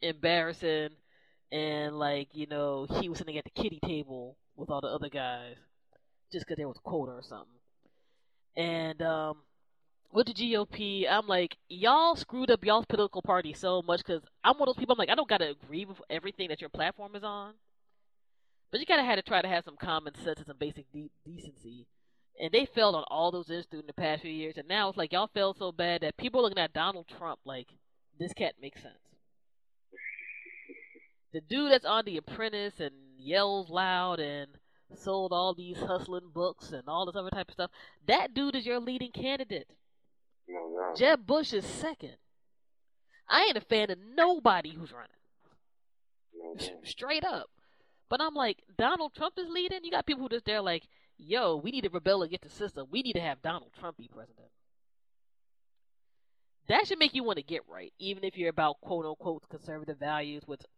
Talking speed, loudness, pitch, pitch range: 195 wpm, -31 LUFS, 180 Hz, 155-215 Hz